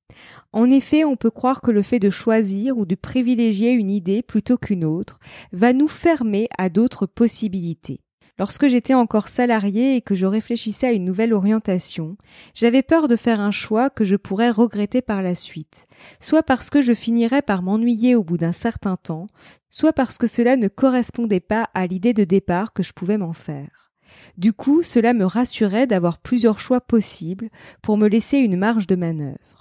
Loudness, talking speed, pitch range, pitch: -19 LUFS, 190 wpm, 195-245 Hz, 220 Hz